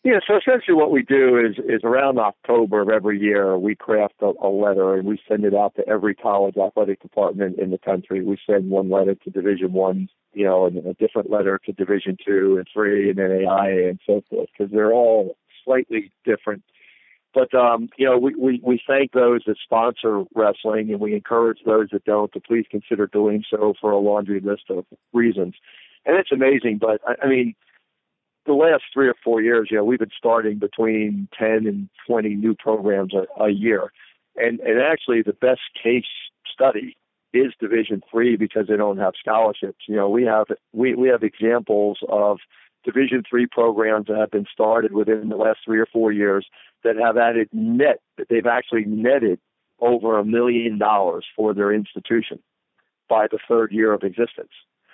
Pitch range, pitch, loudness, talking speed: 100-115 Hz, 110 Hz, -20 LUFS, 190 wpm